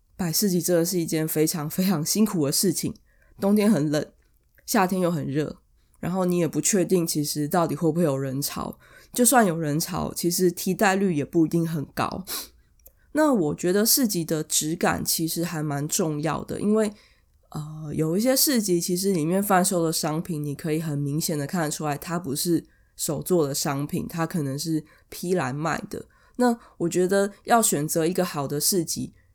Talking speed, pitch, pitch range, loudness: 270 characters per minute, 170 Hz, 150-190 Hz, -24 LUFS